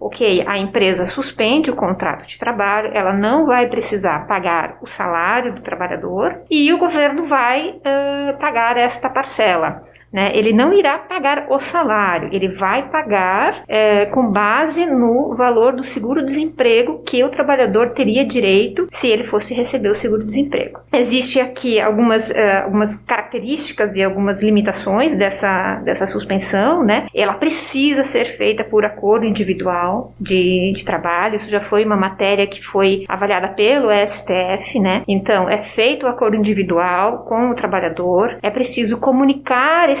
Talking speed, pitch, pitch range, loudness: 150 wpm, 225 Hz, 200-270 Hz, -16 LUFS